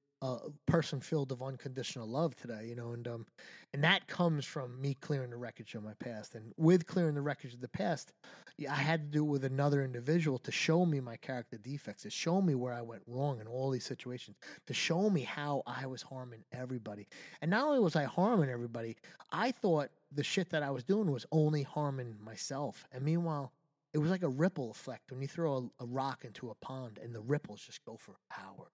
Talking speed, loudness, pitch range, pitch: 220 wpm, -36 LUFS, 125-155 Hz, 140 Hz